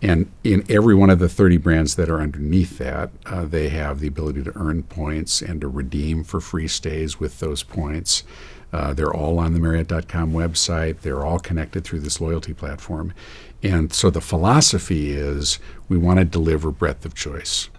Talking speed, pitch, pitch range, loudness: 185 wpm, 80 Hz, 75-90 Hz, -21 LUFS